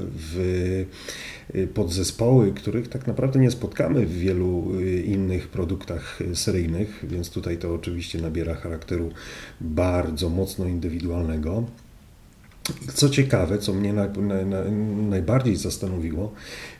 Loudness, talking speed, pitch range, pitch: -25 LUFS, 105 wpm, 85-105 Hz, 95 Hz